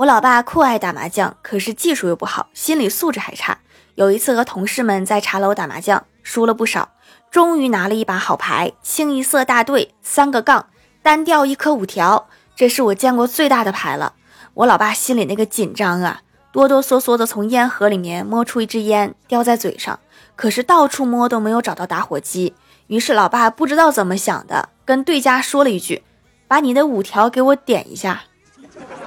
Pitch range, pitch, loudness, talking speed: 210-275 Hz, 240 Hz, -16 LUFS, 290 characters per minute